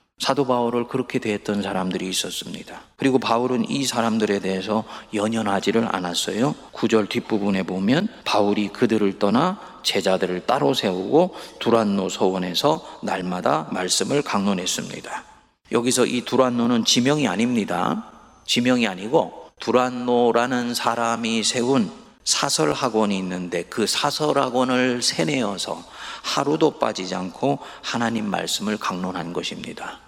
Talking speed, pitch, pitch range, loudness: 315 characters per minute, 115 Hz, 100-125 Hz, -22 LUFS